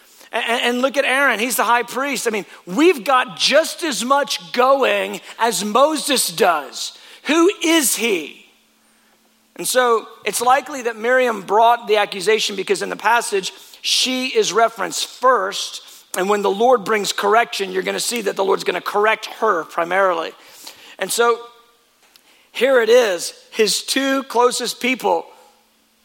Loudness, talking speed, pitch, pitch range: -18 LUFS, 150 wpm, 240 Hz, 220-275 Hz